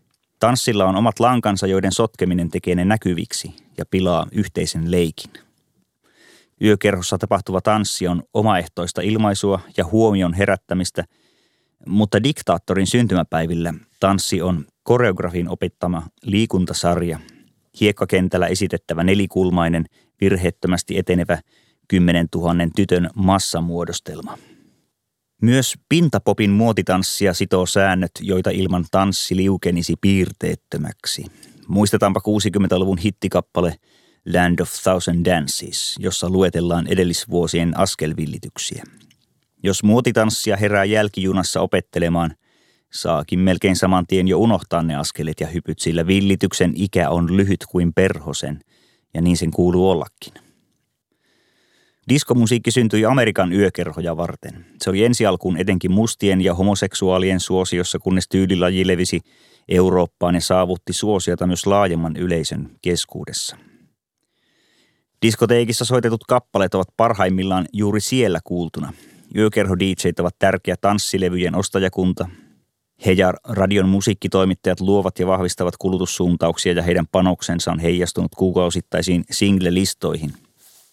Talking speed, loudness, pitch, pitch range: 105 wpm, -19 LUFS, 95 Hz, 90-100 Hz